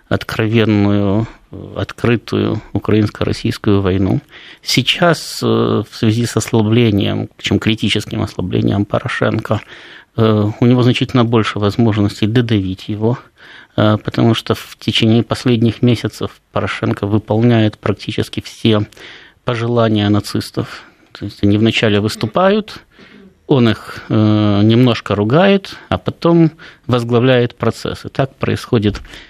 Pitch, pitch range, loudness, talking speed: 115 Hz, 105-120 Hz, -15 LUFS, 95 wpm